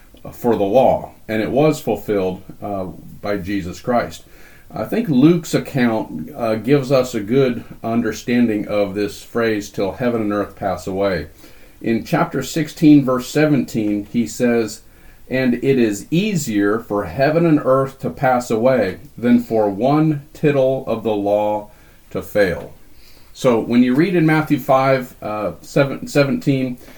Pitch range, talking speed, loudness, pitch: 105-135 Hz, 150 wpm, -18 LUFS, 120 Hz